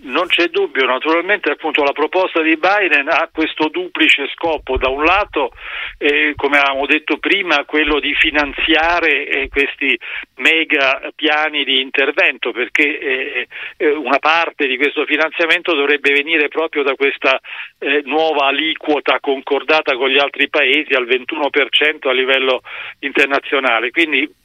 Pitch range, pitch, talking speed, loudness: 140-165 Hz, 150 Hz, 140 wpm, -14 LUFS